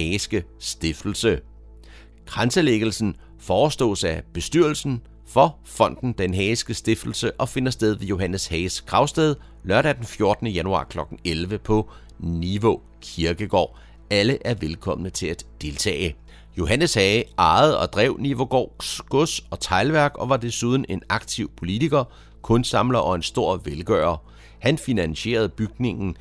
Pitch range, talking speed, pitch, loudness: 85-120 Hz, 130 wpm, 105 Hz, -22 LUFS